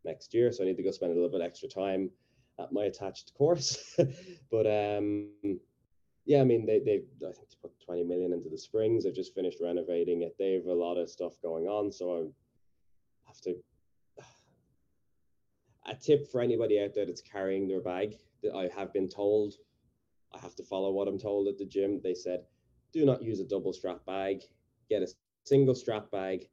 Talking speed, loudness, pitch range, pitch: 205 wpm, -32 LUFS, 90-120 Hz, 100 Hz